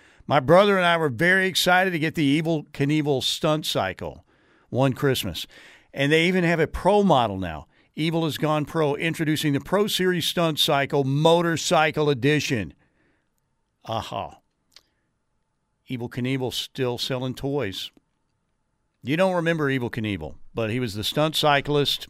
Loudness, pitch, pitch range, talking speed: -22 LUFS, 145 Hz, 125-165 Hz, 145 wpm